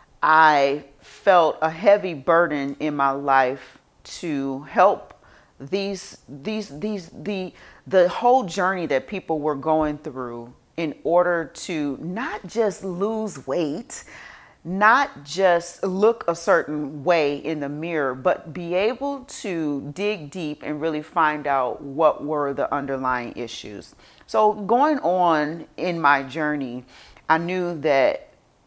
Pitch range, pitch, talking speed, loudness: 145-185 Hz, 160 Hz, 130 wpm, -22 LUFS